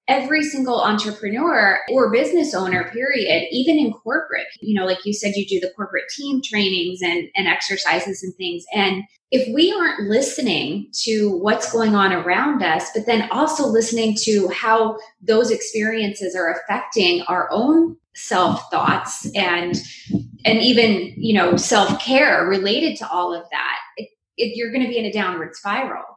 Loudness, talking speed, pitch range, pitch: -19 LUFS, 165 wpm, 190-255 Hz, 220 Hz